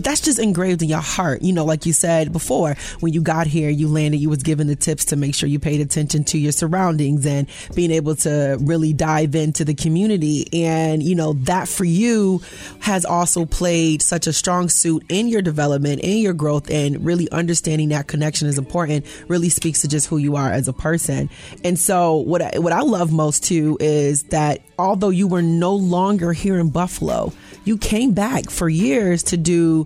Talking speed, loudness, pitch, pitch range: 210 wpm, -18 LUFS, 160 Hz, 150-175 Hz